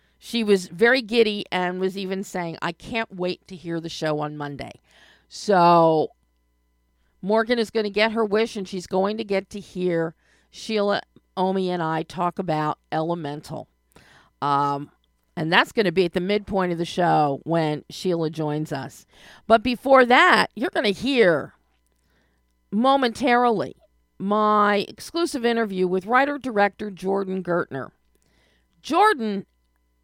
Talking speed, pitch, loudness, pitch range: 145 wpm, 185 Hz, -22 LUFS, 155-220 Hz